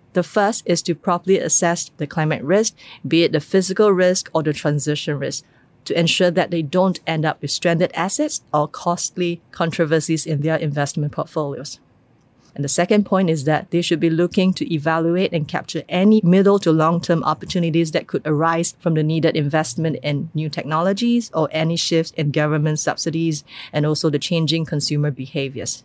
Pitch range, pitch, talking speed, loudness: 155-175 Hz, 165 Hz, 175 wpm, -19 LUFS